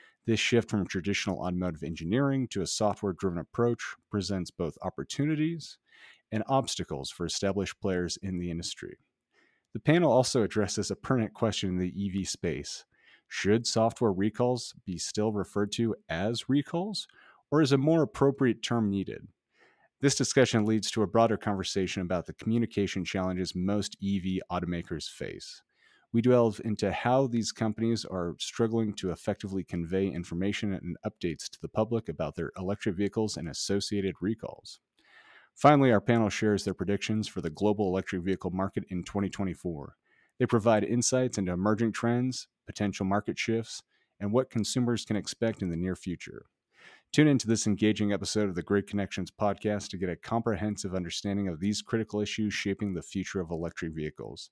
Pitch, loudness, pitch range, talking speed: 105 Hz, -30 LUFS, 95-115 Hz, 160 wpm